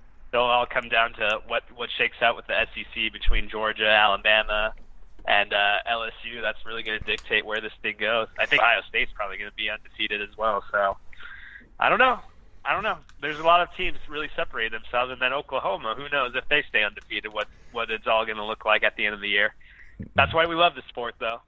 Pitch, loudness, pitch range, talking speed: 110 Hz, -24 LUFS, 110-140 Hz, 235 wpm